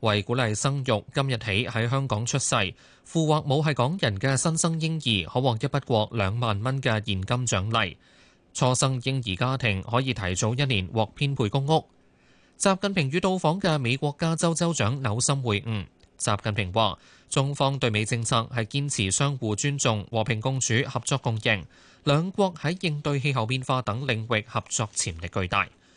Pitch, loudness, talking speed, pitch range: 120 Hz, -26 LUFS, 265 characters per minute, 110-140 Hz